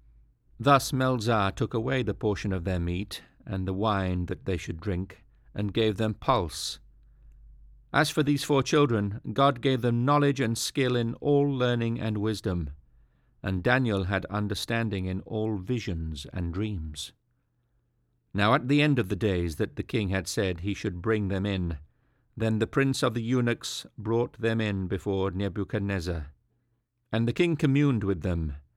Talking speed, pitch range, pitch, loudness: 165 wpm, 95-120 Hz, 110 Hz, -28 LUFS